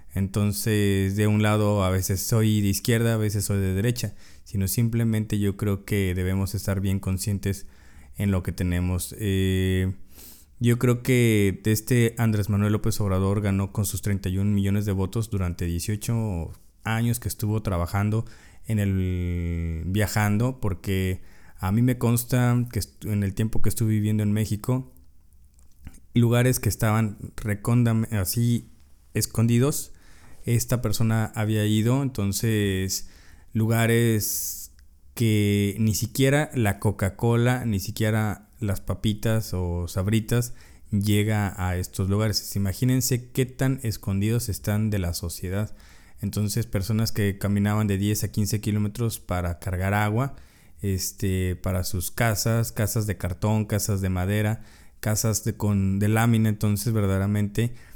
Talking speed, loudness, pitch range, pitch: 135 wpm, -25 LUFS, 95-110 Hz, 105 Hz